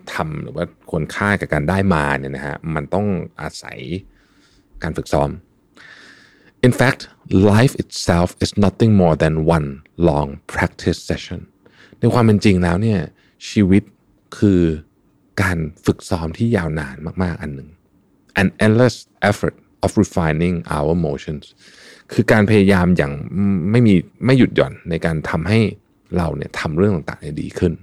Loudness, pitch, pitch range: -18 LUFS, 95 Hz, 80-105 Hz